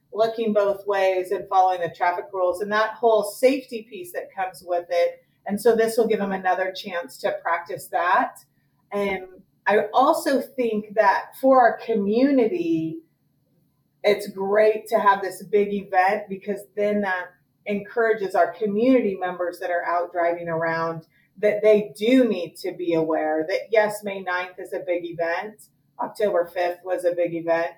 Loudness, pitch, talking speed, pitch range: -23 LUFS, 195 Hz, 165 wpm, 175-215 Hz